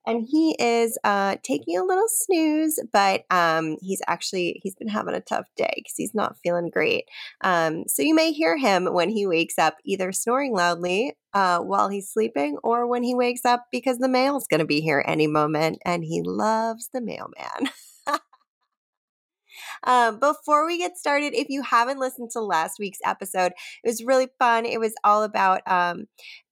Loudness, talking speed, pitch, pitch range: -23 LUFS, 185 wpm, 225 Hz, 180-265 Hz